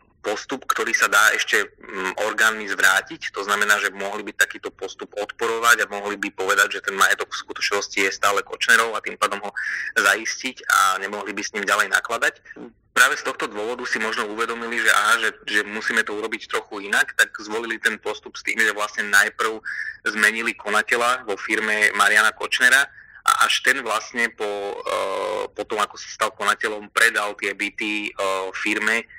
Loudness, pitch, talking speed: -21 LUFS, 115 Hz, 175 wpm